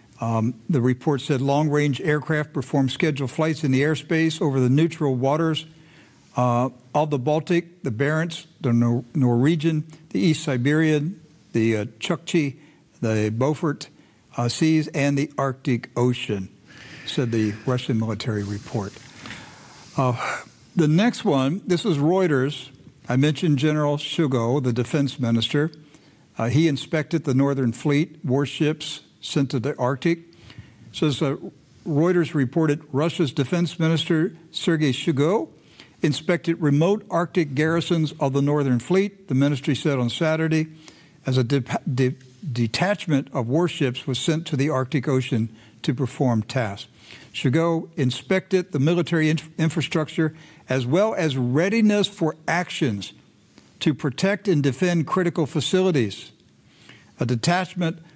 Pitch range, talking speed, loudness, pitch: 130-165 Hz, 130 wpm, -23 LUFS, 150 Hz